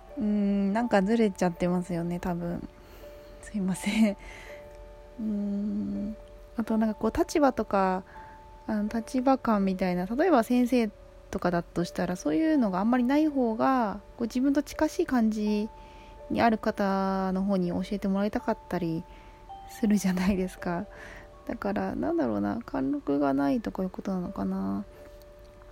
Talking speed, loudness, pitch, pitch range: 310 characters per minute, -28 LUFS, 200 Hz, 175-230 Hz